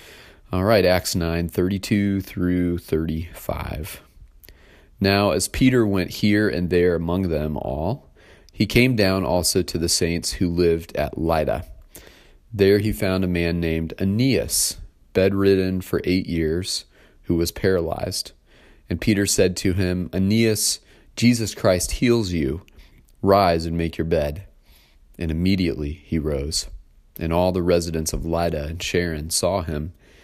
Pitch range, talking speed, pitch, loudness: 80-95 Hz, 140 wpm, 90 Hz, -21 LUFS